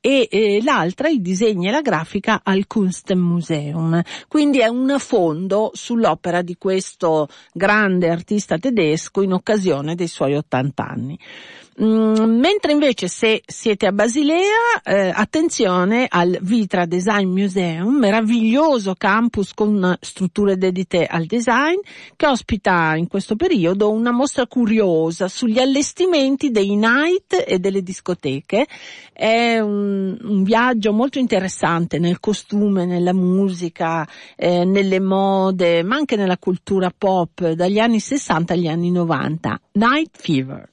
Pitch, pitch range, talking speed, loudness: 200 Hz, 175-235 Hz, 125 wpm, -18 LUFS